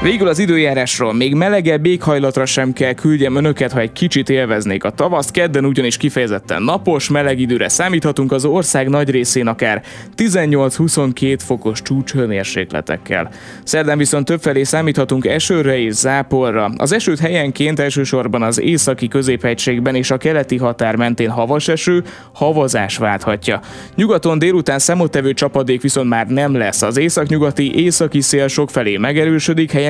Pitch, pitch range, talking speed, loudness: 135 Hz, 125-150 Hz, 140 wpm, -15 LUFS